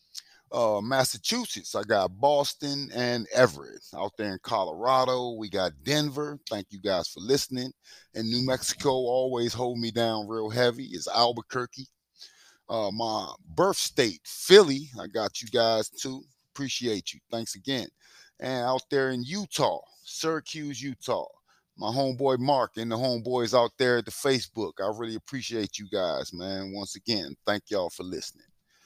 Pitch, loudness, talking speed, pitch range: 125 Hz, -28 LUFS, 155 wpm, 110-135 Hz